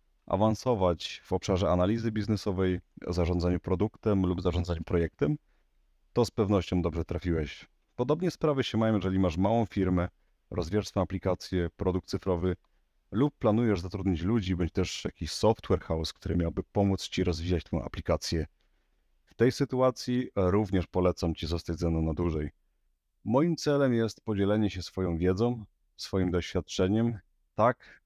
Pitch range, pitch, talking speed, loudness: 85-110 Hz, 95 Hz, 135 wpm, -30 LUFS